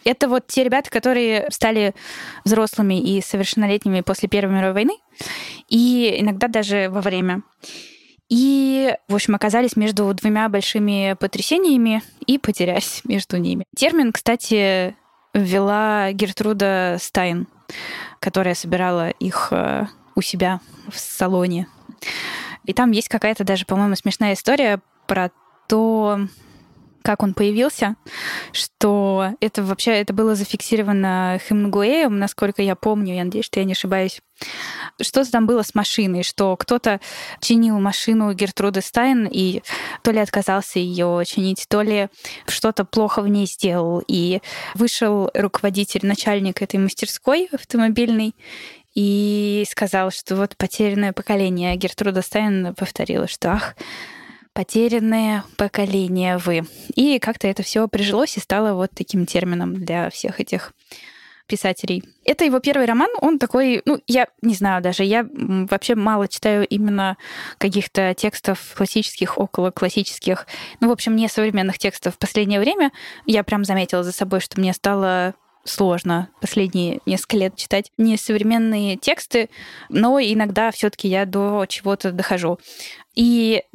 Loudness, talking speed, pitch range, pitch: -20 LUFS, 130 wpm, 190-225 Hz, 205 Hz